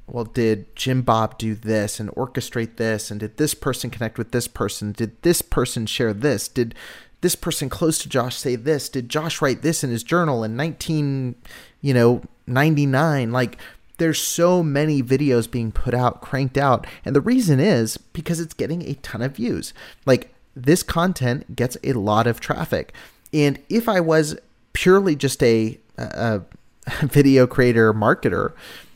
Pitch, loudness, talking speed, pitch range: 130 Hz, -21 LUFS, 170 wpm, 115-150 Hz